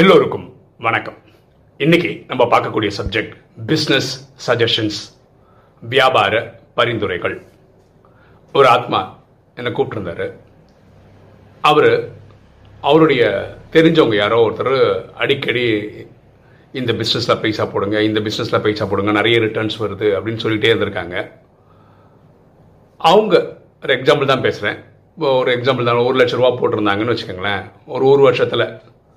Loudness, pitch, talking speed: -16 LUFS, 130 Hz, 105 wpm